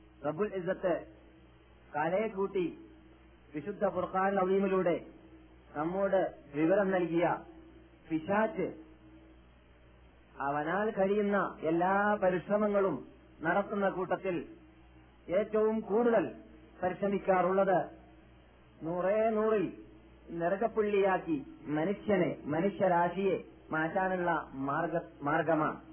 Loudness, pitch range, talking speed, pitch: -32 LUFS, 150-200 Hz, 60 wpm, 185 Hz